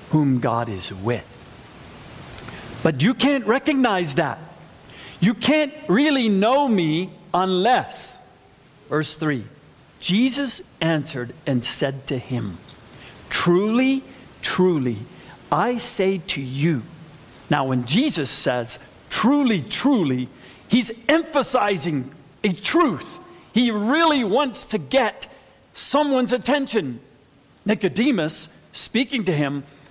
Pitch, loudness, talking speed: 180 Hz, -21 LUFS, 100 wpm